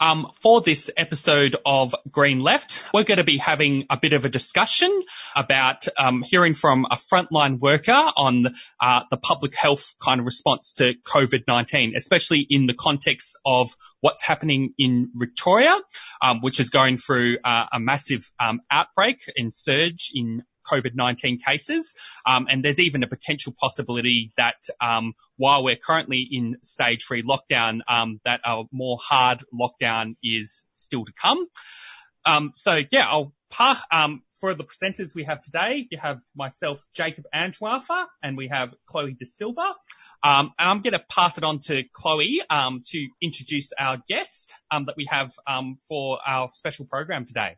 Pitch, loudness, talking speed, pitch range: 140 Hz, -21 LUFS, 165 wpm, 125-160 Hz